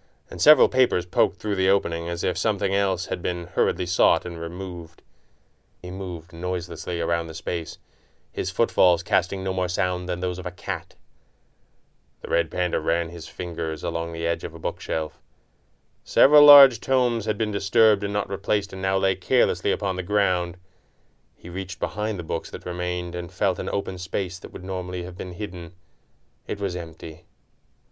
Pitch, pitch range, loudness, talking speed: 90 Hz, 85-100 Hz, -24 LUFS, 180 wpm